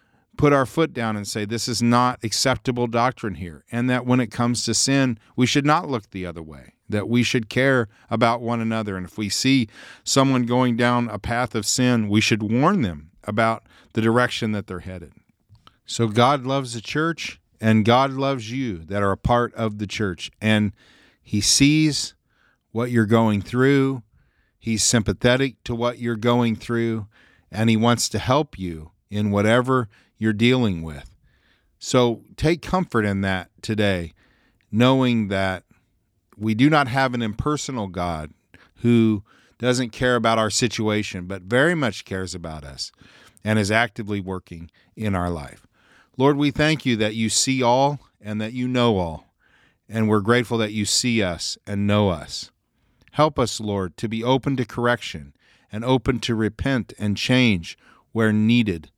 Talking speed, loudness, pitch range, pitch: 170 wpm, -21 LUFS, 100-125 Hz, 115 Hz